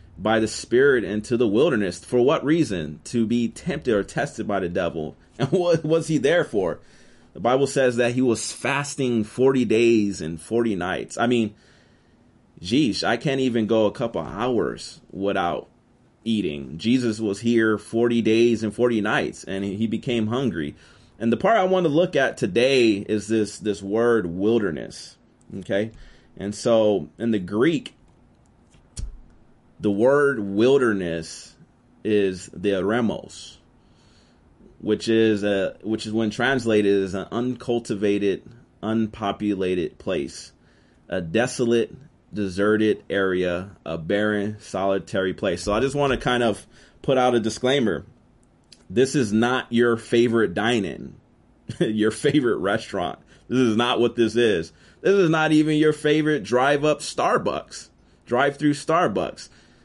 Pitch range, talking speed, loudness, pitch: 100-125 Hz, 140 wpm, -22 LUFS, 110 Hz